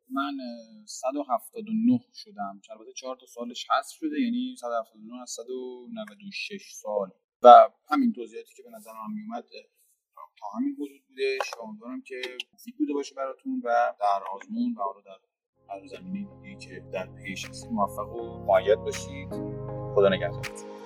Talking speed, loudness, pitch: 140 wpm, -26 LUFS, 185 Hz